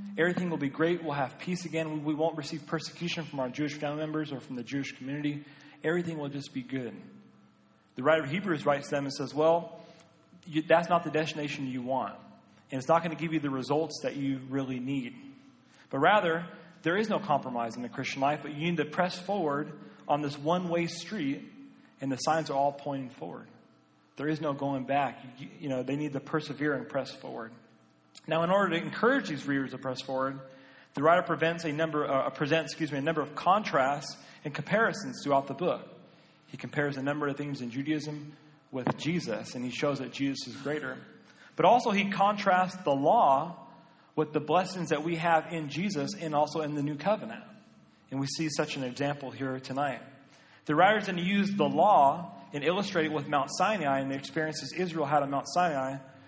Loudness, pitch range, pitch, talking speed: -30 LUFS, 140-165 Hz, 150 Hz, 205 wpm